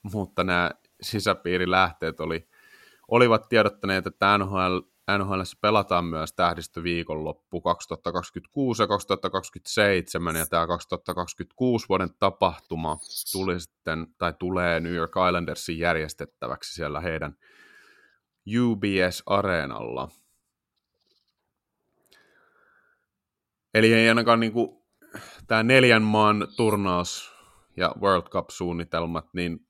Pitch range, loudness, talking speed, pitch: 85-110 Hz, -25 LUFS, 85 wpm, 90 Hz